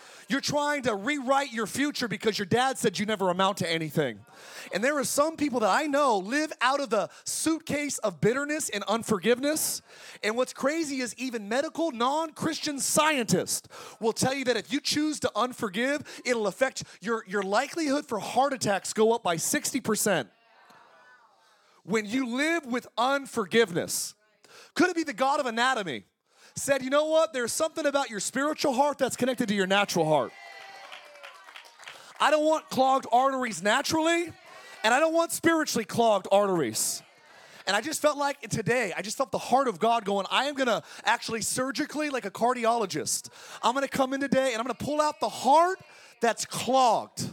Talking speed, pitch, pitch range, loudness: 175 wpm, 255 Hz, 220-285 Hz, -27 LUFS